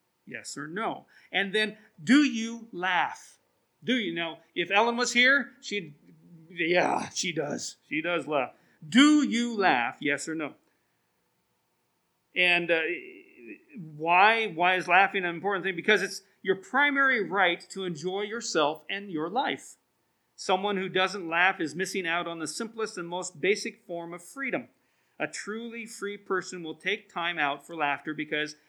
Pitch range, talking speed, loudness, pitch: 170-220 Hz, 155 wpm, -27 LUFS, 190 Hz